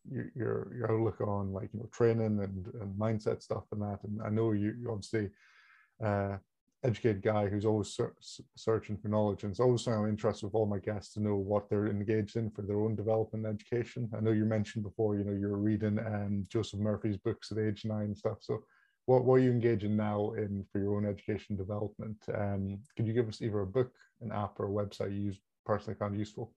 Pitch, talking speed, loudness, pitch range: 105 Hz, 230 wpm, -34 LUFS, 100-110 Hz